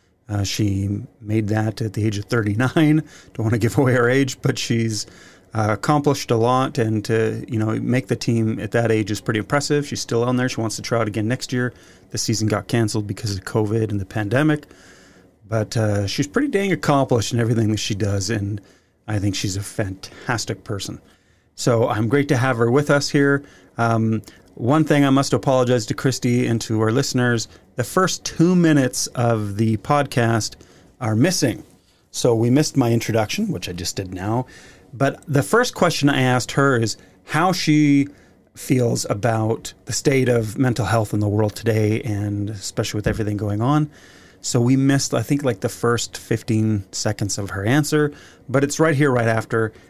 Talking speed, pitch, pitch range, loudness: 195 wpm, 115 Hz, 105-135 Hz, -20 LUFS